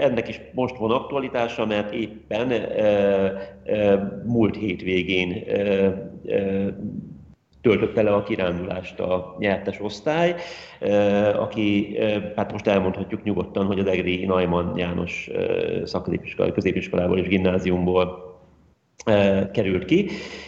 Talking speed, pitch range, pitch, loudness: 110 wpm, 90-105 Hz, 100 Hz, -23 LUFS